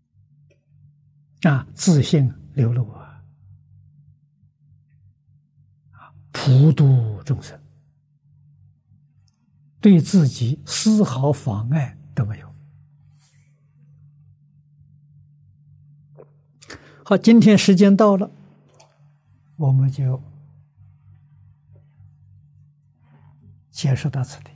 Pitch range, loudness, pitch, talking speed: 130-145 Hz, -18 LUFS, 140 Hz, 90 characters per minute